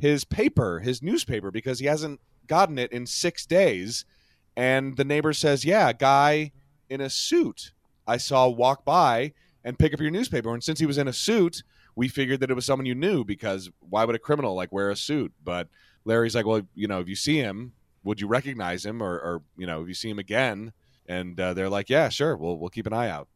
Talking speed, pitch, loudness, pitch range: 230 wpm, 125 Hz, -25 LUFS, 100-145 Hz